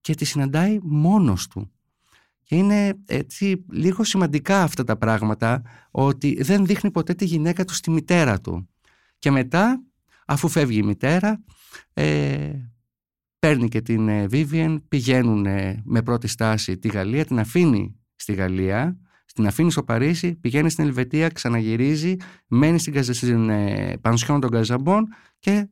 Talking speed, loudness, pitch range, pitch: 135 wpm, -21 LUFS, 115-170 Hz, 140 Hz